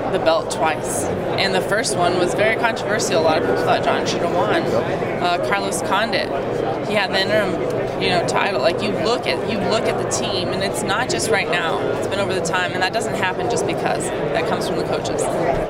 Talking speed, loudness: 230 wpm, -19 LUFS